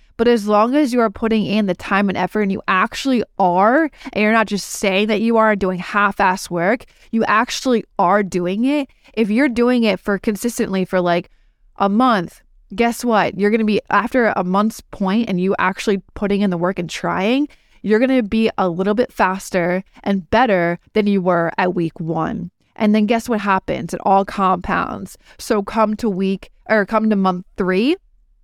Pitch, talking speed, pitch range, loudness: 205 Hz, 200 wpm, 190-225 Hz, -18 LUFS